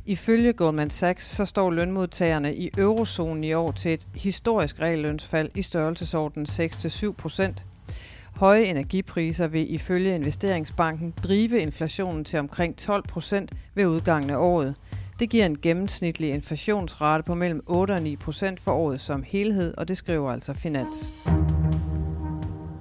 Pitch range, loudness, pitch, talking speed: 145-185 Hz, -25 LUFS, 165 Hz, 135 wpm